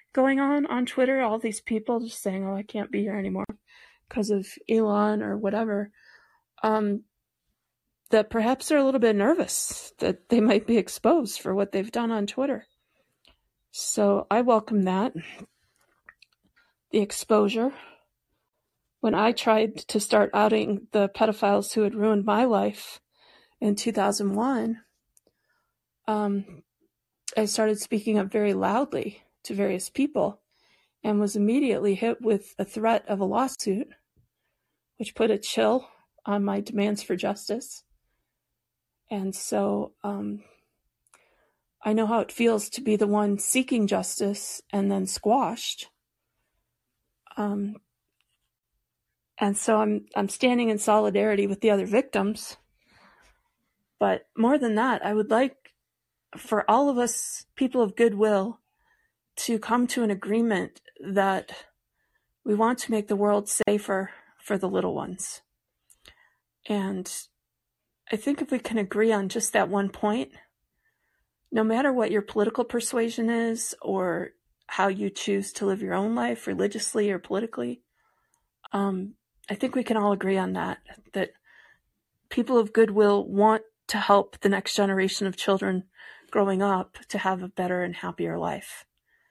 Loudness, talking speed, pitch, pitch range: -26 LUFS, 140 wpm, 215 Hz, 200-230 Hz